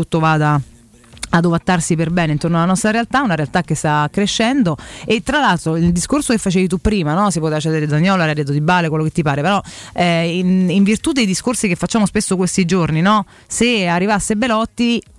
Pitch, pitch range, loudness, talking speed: 180 Hz, 160-215 Hz, -16 LUFS, 205 wpm